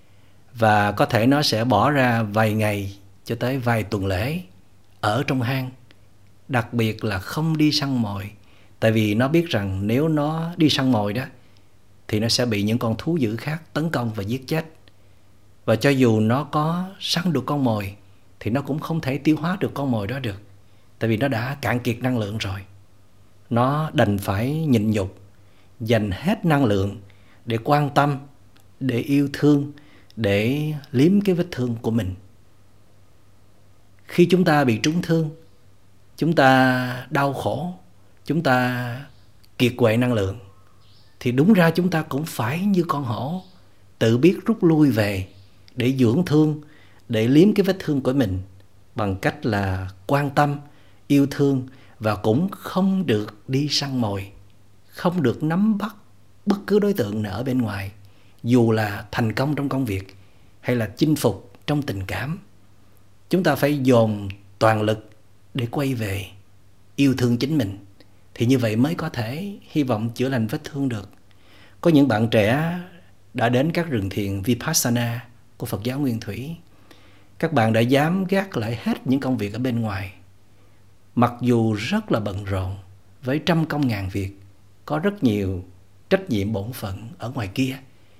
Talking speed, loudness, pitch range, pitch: 175 wpm, -22 LUFS, 100-140 Hz, 115 Hz